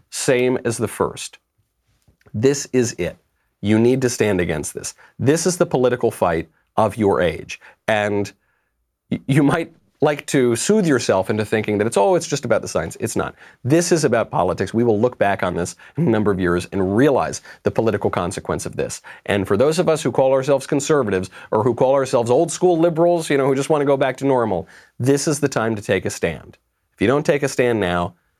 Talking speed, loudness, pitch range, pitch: 220 wpm, -19 LUFS, 105-145 Hz, 125 Hz